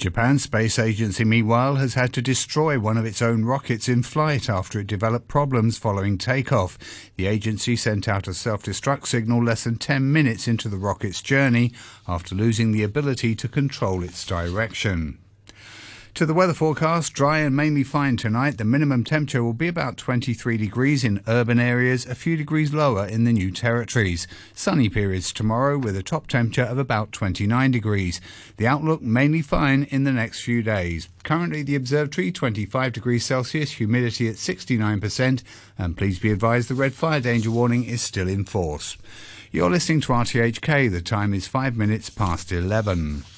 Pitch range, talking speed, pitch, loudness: 105-135 Hz, 175 wpm, 115 Hz, -22 LUFS